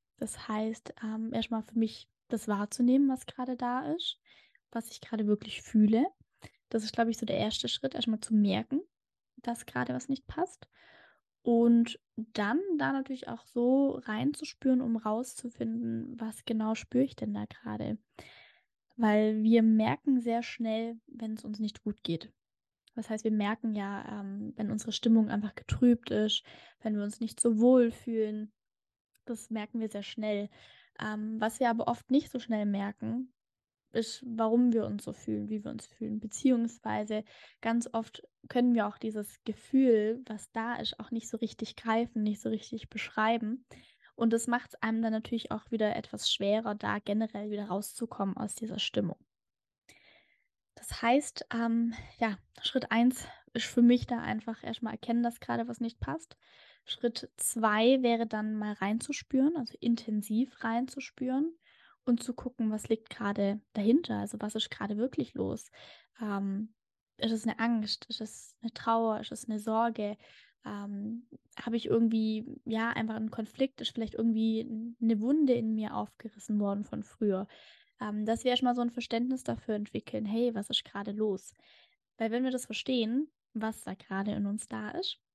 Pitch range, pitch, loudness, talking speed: 215-240 Hz, 225 Hz, -32 LUFS, 170 wpm